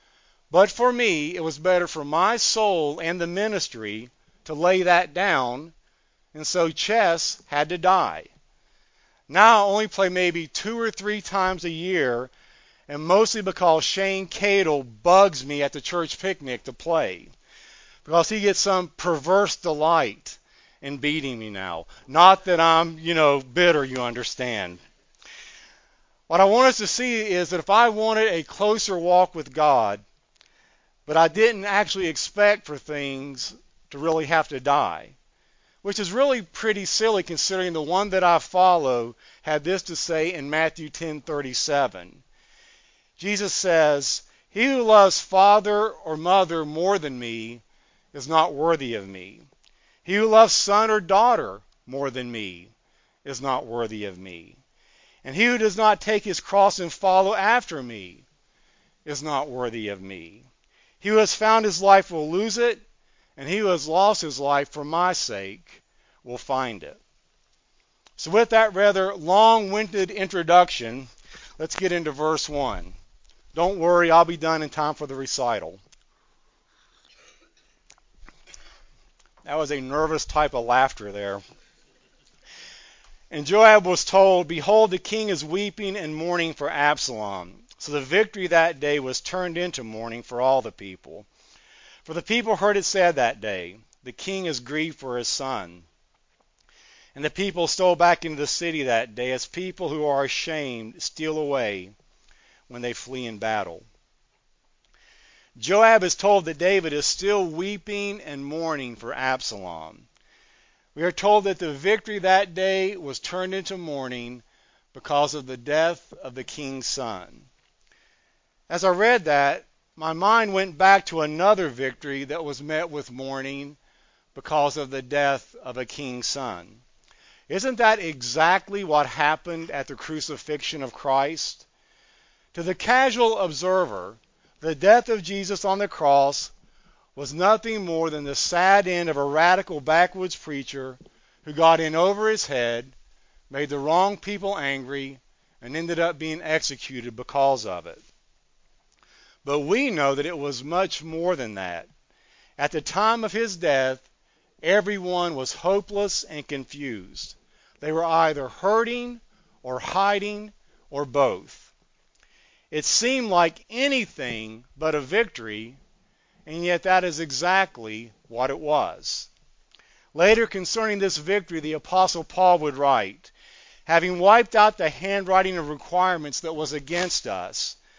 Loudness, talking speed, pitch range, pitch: -22 LUFS, 150 wpm, 140-195 Hz, 165 Hz